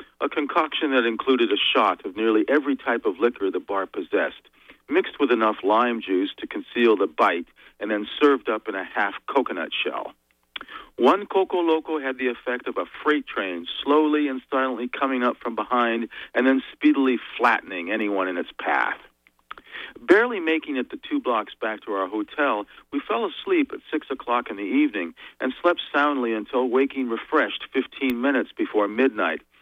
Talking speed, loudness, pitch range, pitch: 175 wpm, -23 LUFS, 115-150 Hz, 130 Hz